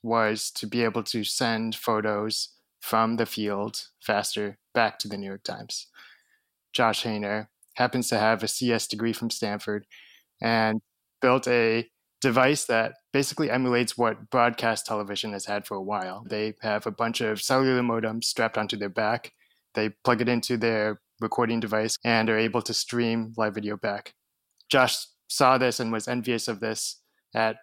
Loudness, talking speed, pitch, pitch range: -26 LUFS, 165 wpm, 115 Hz, 110-120 Hz